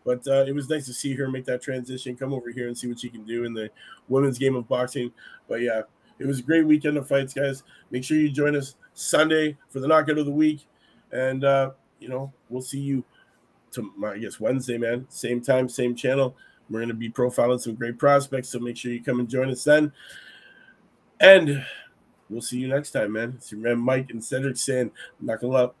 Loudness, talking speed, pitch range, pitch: -24 LUFS, 225 wpm, 120-140 Hz, 130 Hz